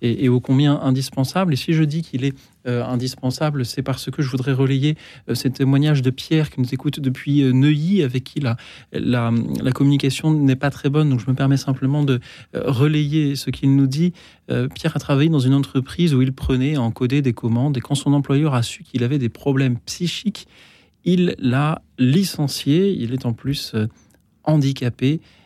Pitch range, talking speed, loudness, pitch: 130-150 Hz, 205 wpm, -20 LUFS, 135 Hz